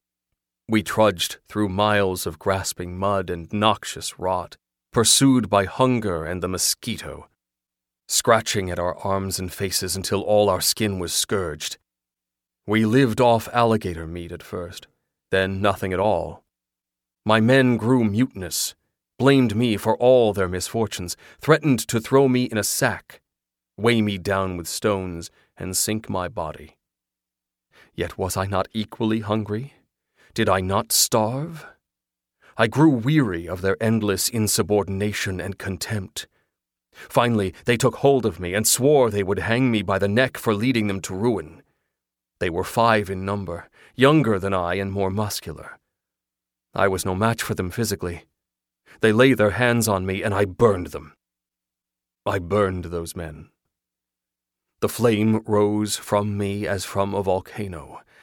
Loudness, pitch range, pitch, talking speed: -21 LUFS, 85-110 Hz, 100 Hz, 150 wpm